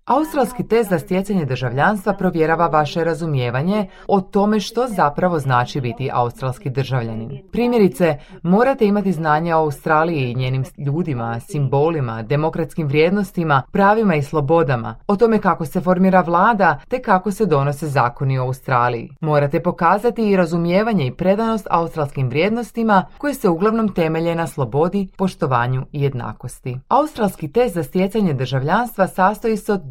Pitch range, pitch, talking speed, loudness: 140-200 Hz, 165 Hz, 140 wpm, -18 LUFS